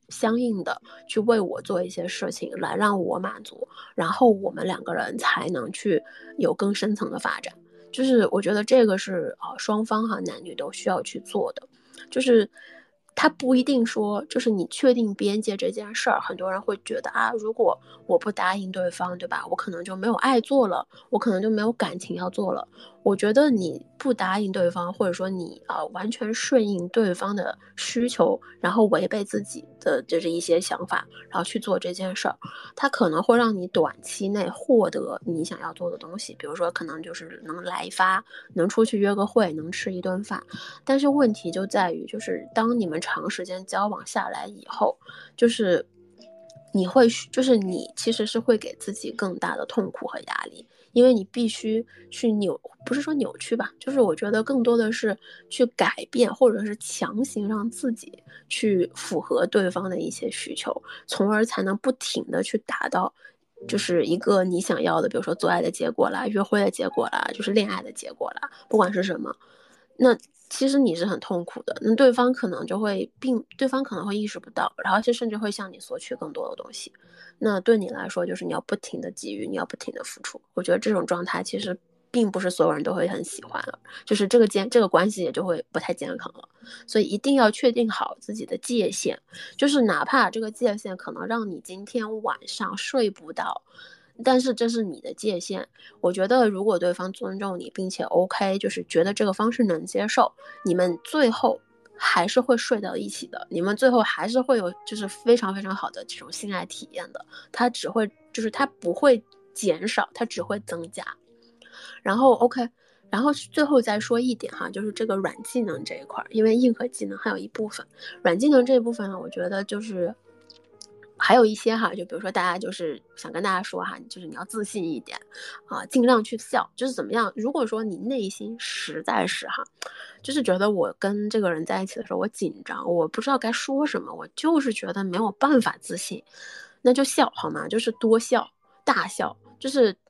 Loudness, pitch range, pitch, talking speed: -25 LUFS, 195-255 Hz, 225 Hz, 295 characters per minute